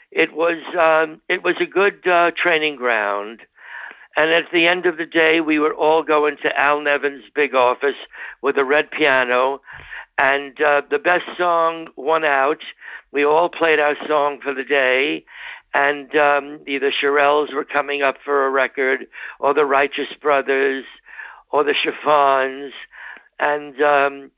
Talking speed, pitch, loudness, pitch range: 160 wpm, 145 Hz, -18 LUFS, 140-160 Hz